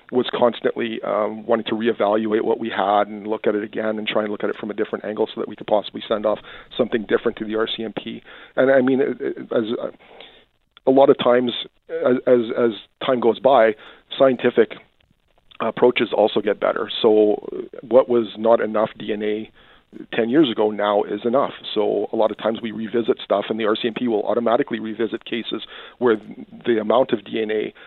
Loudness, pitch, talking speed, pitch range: -20 LUFS, 110 Hz, 190 wpm, 110-120 Hz